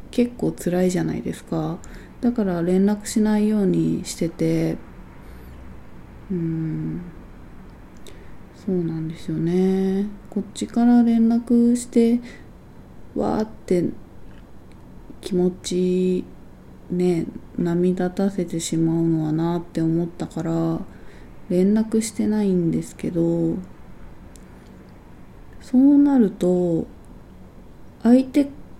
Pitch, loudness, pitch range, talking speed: 180 Hz, -21 LUFS, 165-210 Hz, 170 characters per minute